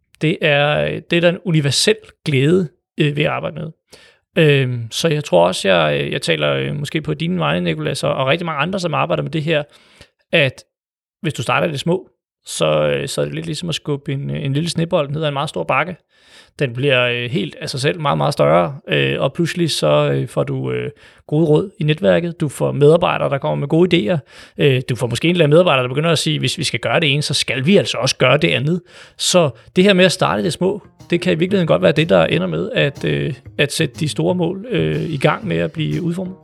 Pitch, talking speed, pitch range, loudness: 155 Hz, 225 wpm, 135-175 Hz, -17 LUFS